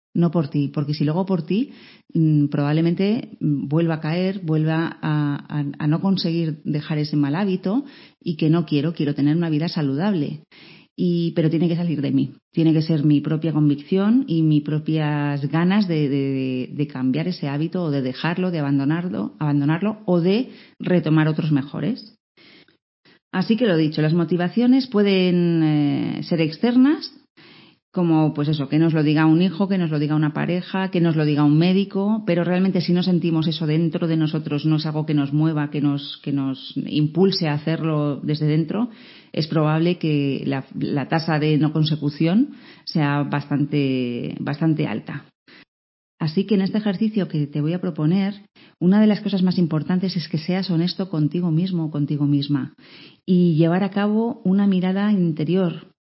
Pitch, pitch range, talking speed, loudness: 160 Hz, 150-185 Hz, 180 wpm, -21 LUFS